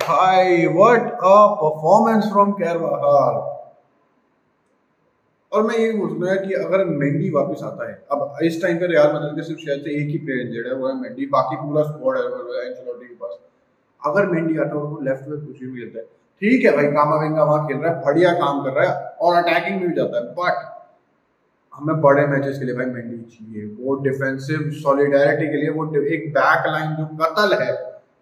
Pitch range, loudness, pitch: 145-195 Hz, -19 LUFS, 155 Hz